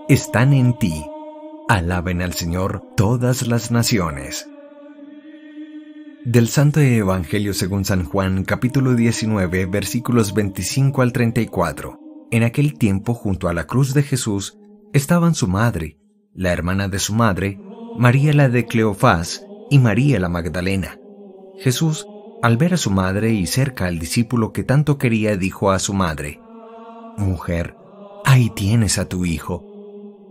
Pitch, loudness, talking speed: 120 Hz, -19 LUFS, 135 wpm